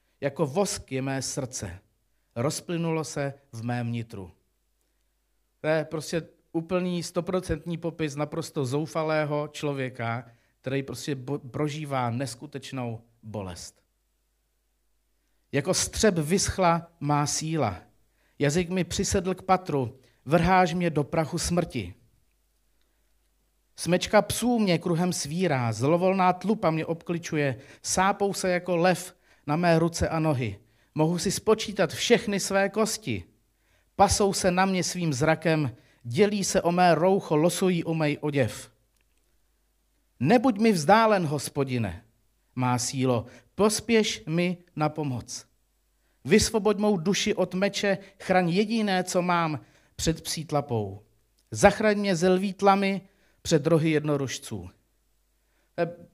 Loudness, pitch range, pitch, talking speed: -26 LUFS, 125-180 Hz, 155 Hz, 115 wpm